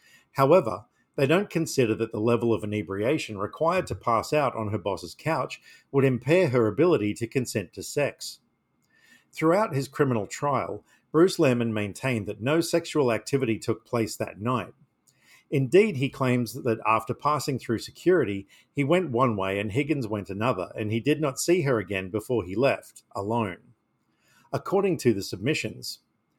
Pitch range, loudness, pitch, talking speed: 110-145 Hz, -26 LUFS, 120 Hz, 160 wpm